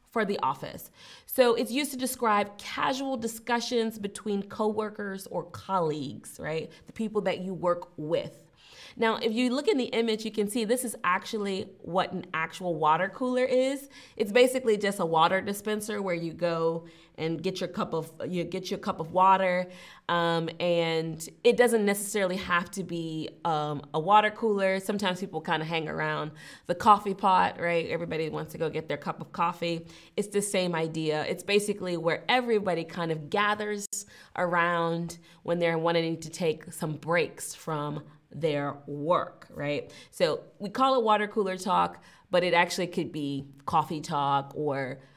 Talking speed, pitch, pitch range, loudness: 175 wpm, 180 Hz, 165-210 Hz, -28 LUFS